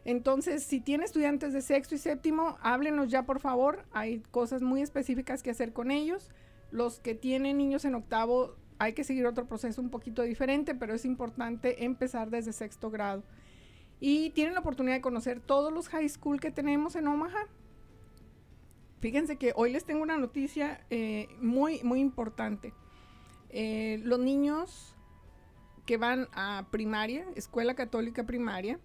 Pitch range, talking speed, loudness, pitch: 235-290 Hz, 160 wpm, -32 LUFS, 255 Hz